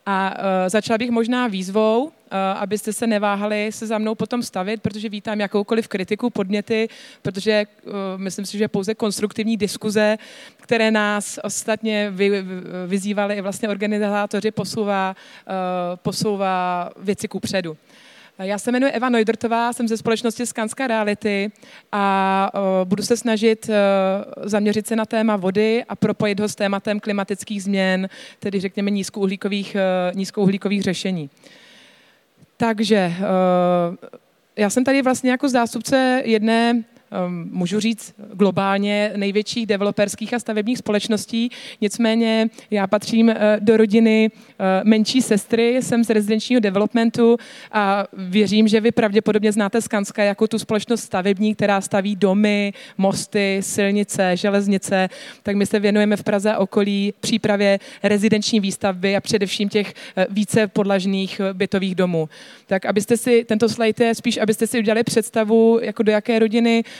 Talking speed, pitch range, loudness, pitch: 130 wpm, 200-225 Hz, -20 LUFS, 210 Hz